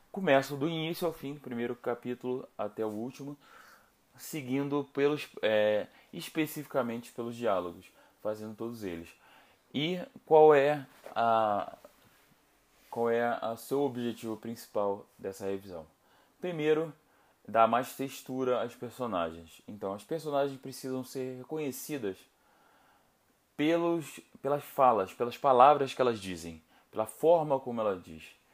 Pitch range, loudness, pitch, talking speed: 110-145 Hz, -31 LUFS, 125 Hz, 120 wpm